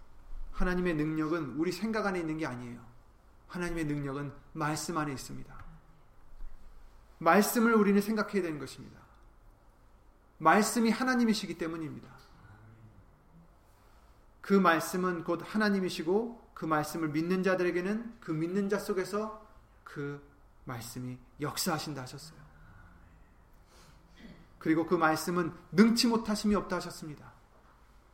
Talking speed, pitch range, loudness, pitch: 270 characters per minute, 120-185 Hz, -31 LUFS, 160 Hz